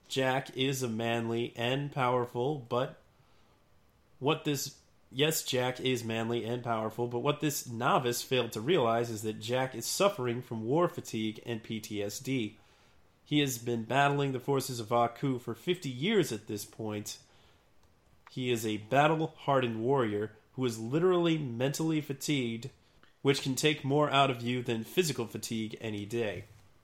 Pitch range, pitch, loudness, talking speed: 115-140 Hz, 120 Hz, -32 LUFS, 155 wpm